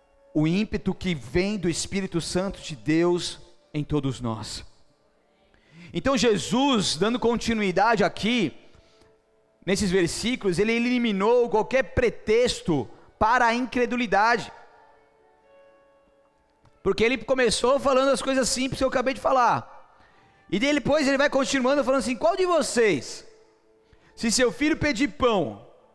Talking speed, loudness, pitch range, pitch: 125 wpm, -24 LUFS, 180-265 Hz, 230 Hz